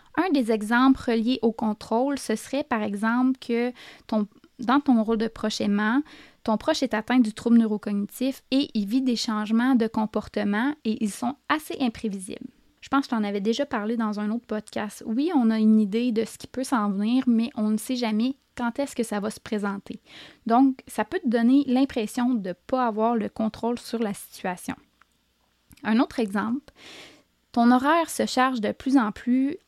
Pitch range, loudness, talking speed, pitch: 220-260 Hz, -25 LUFS, 200 wpm, 235 Hz